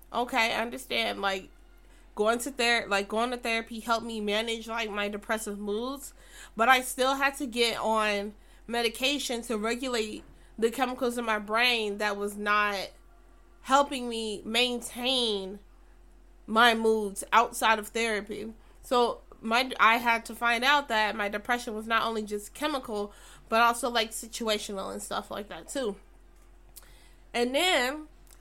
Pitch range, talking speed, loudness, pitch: 210-240 Hz, 150 wpm, -28 LUFS, 225 Hz